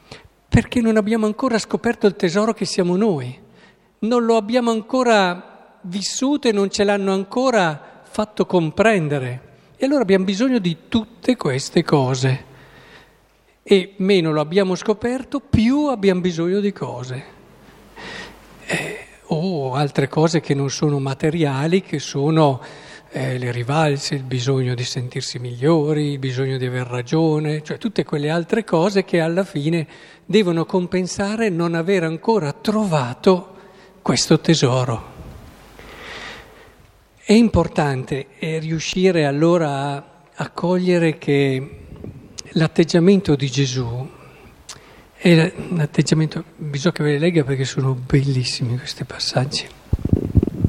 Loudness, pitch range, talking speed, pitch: -19 LUFS, 140-200 Hz, 120 wpm, 165 Hz